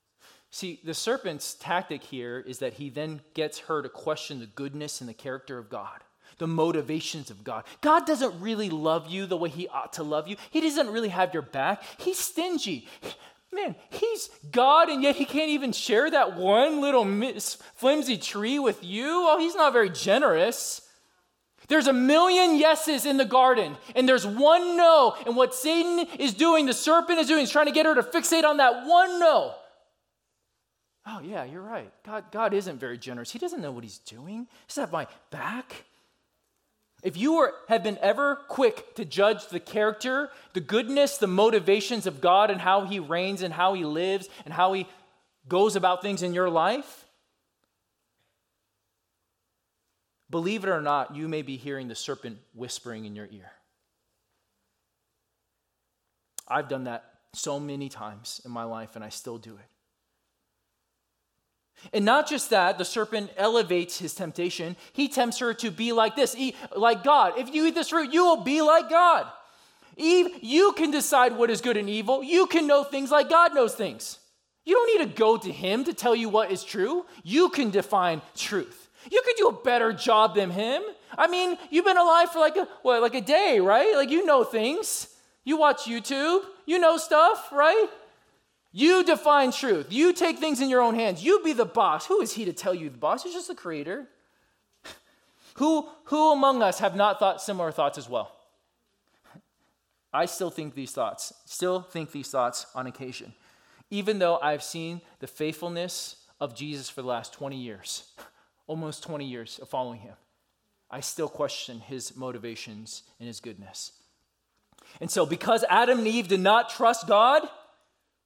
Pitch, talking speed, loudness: 215 Hz, 180 wpm, -24 LUFS